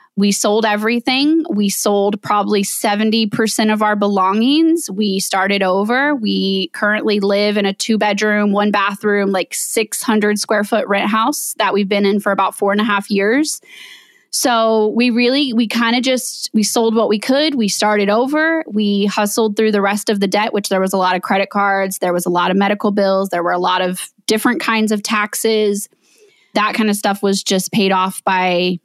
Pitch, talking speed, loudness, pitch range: 210 Hz, 200 wpm, -15 LUFS, 200-225 Hz